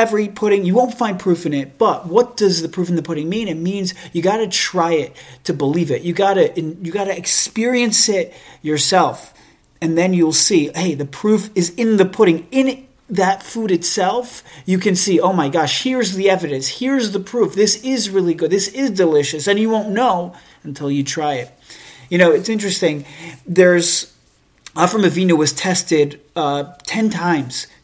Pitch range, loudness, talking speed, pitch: 160-210 Hz, -16 LUFS, 185 wpm, 185 Hz